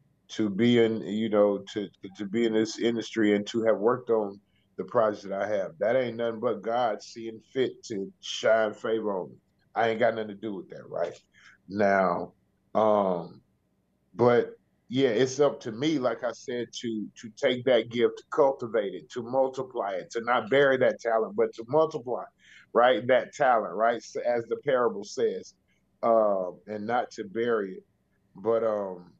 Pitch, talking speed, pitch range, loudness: 115 Hz, 185 wpm, 105-125 Hz, -27 LUFS